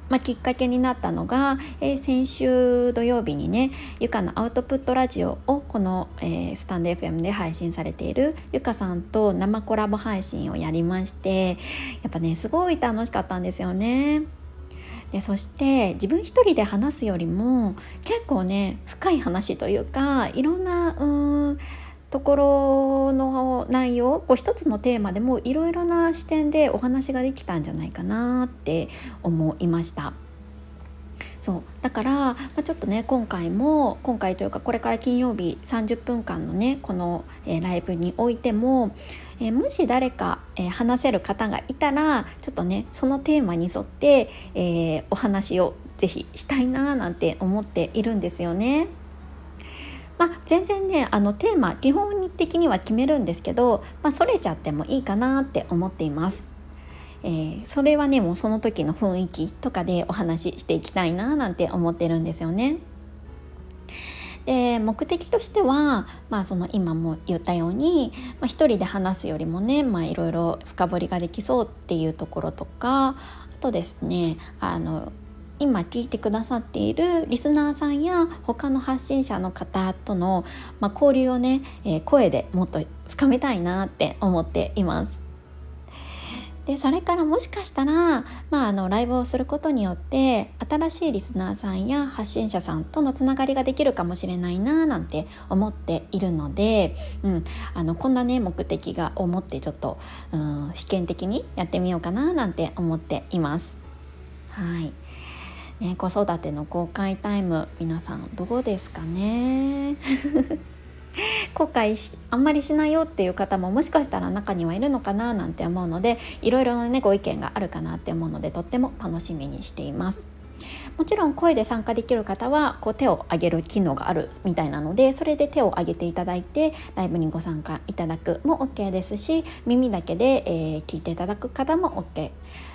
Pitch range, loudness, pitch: 170-270 Hz, -24 LUFS, 220 Hz